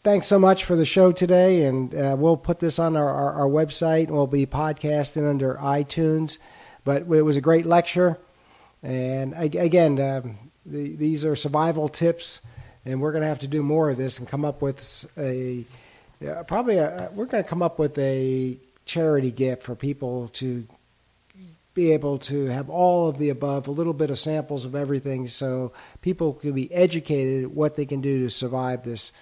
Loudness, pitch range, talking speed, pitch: -23 LUFS, 130-160 Hz, 195 wpm, 145 Hz